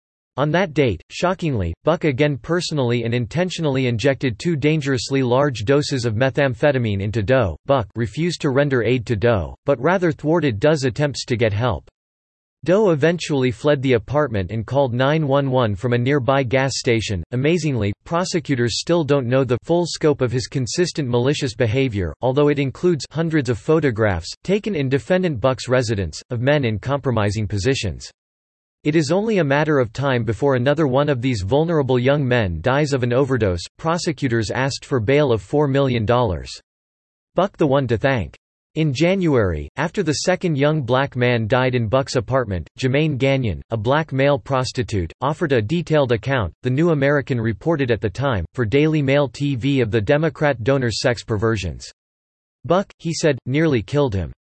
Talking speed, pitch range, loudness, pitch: 165 wpm, 115-150 Hz, -19 LUFS, 135 Hz